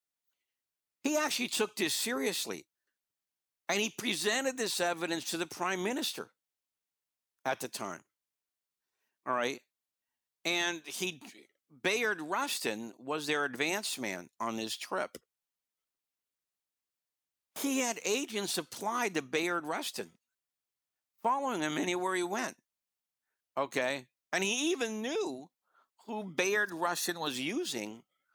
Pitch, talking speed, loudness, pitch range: 175 Hz, 110 wpm, -33 LUFS, 135-215 Hz